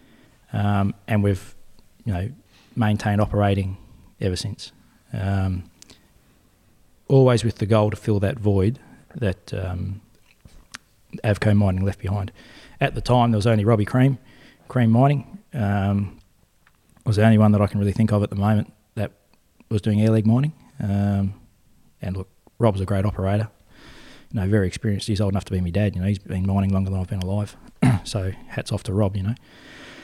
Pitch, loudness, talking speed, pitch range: 105 Hz, -22 LUFS, 175 wpm, 100-115 Hz